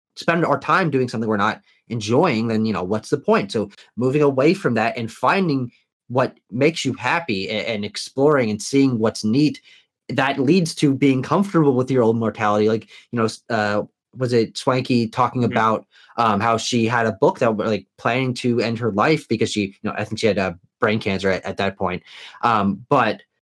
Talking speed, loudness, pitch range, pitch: 205 wpm, -20 LUFS, 110-140 Hz, 115 Hz